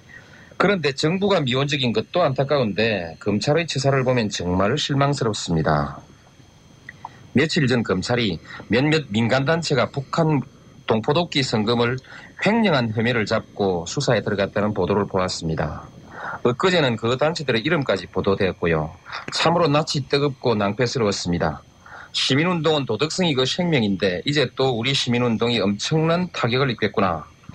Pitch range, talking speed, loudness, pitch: 105-150 Hz, 325 characters per minute, -21 LUFS, 125 Hz